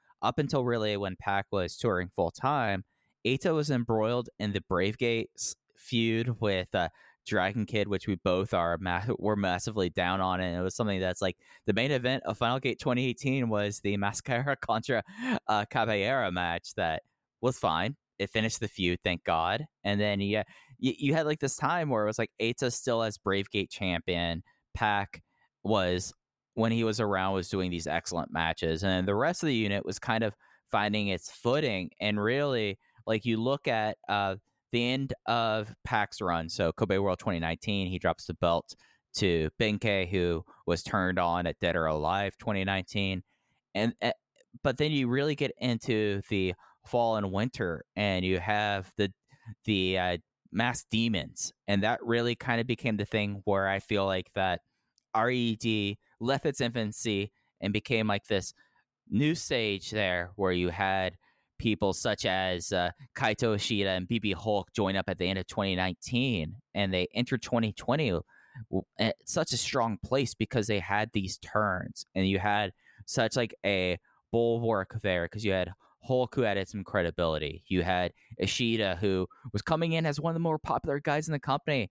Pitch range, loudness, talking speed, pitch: 95-120 Hz, -30 LUFS, 175 wpm, 105 Hz